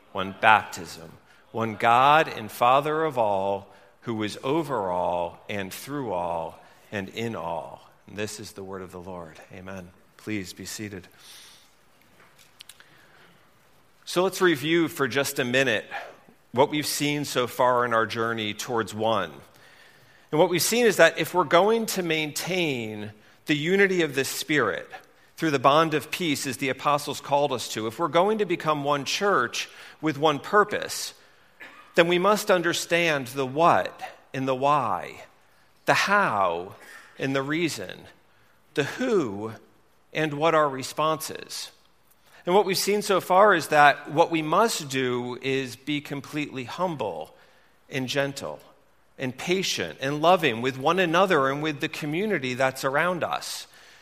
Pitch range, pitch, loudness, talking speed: 115-165 Hz, 140 Hz, -24 LUFS, 150 wpm